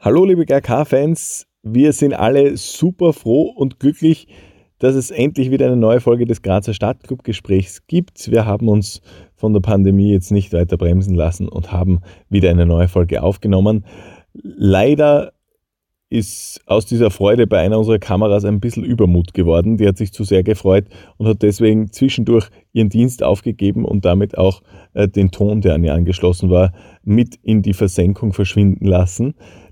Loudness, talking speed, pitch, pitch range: -15 LUFS, 165 wpm, 105 Hz, 95-115 Hz